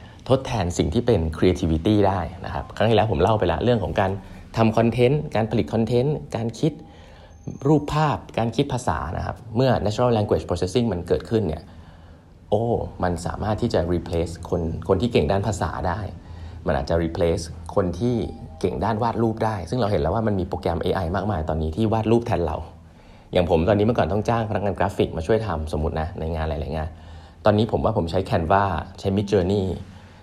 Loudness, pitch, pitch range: -23 LUFS, 100 Hz, 85-110 Hz